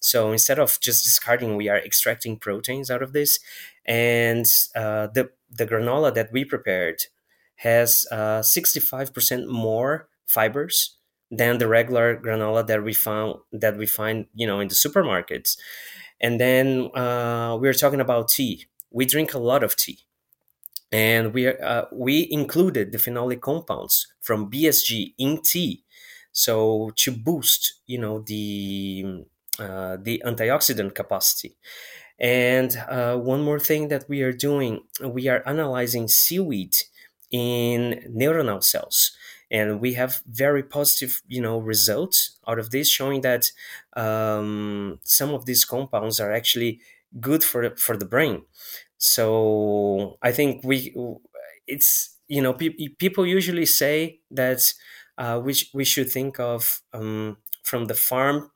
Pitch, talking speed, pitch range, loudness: 120 Hz, 145 wpm, 110-135 Hz, -21 LUFS